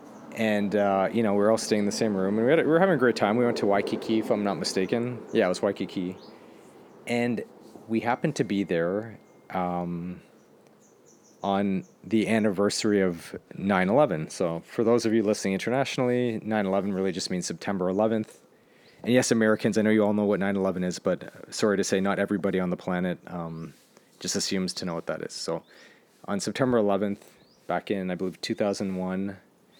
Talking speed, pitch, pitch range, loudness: 200 wpm, 100 Hz, 95-110 Hz, -26 LUFS